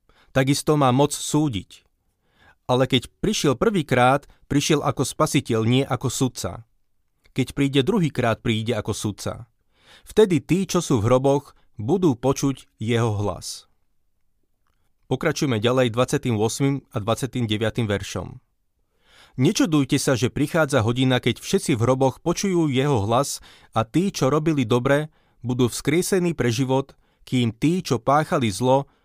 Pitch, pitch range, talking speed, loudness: 130 Hz, 115-145 Hz, 130 wpm, -22 LUFS